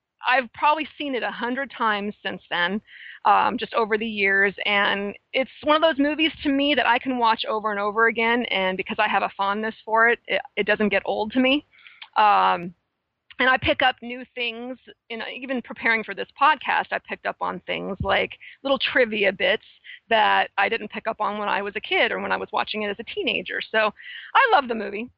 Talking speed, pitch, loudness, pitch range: 220 wpm, 230 Hz, -22 LUFS, 205-260 Hz